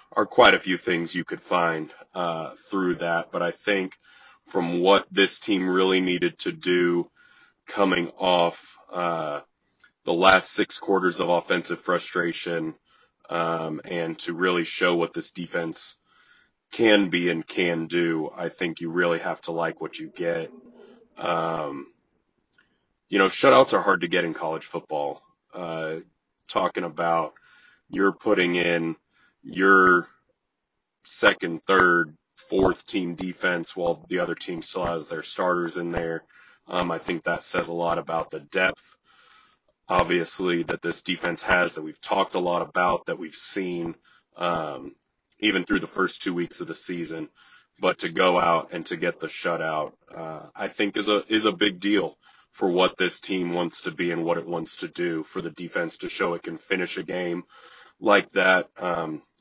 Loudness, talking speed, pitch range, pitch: -24 LUFS, 170 wpm, 85-90 Hz, 85 Hz